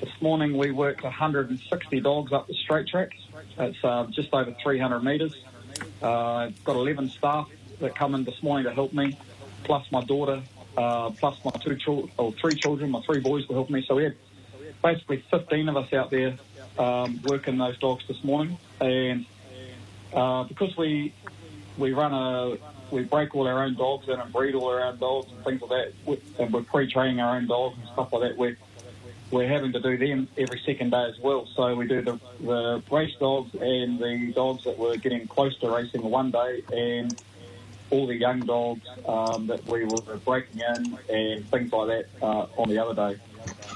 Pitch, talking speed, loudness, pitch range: 125 Hz, 200 wpm, -27 LUFS, 120-135 Hz